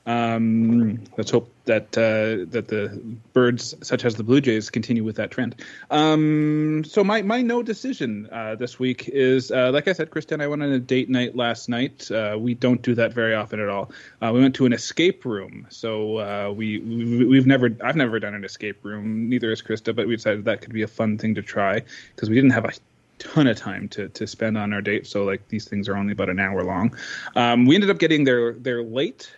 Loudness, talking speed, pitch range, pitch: -22 LUFS, 235 wpm, 110-130 Hz, 115 Hz